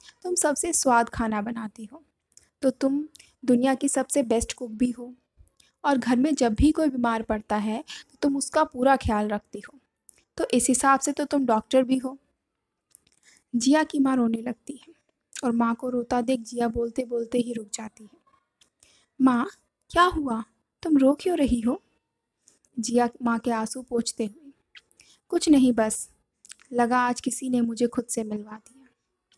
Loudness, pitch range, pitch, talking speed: -25 LUFS, 235-280 Hz, 250 Hz, 170 wpm